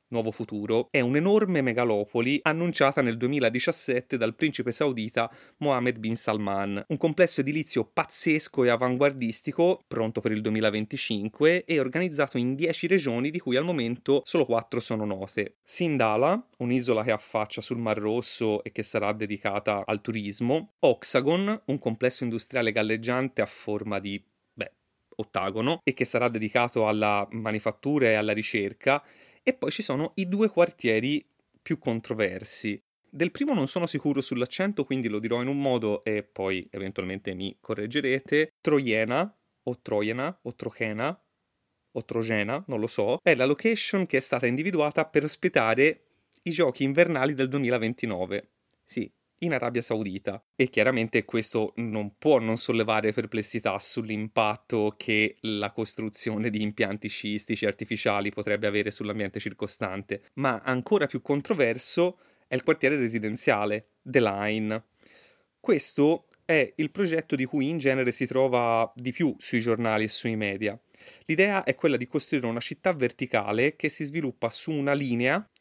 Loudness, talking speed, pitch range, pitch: -27 LUFS, 145 wpm, 110-145 Hz, 120 Hz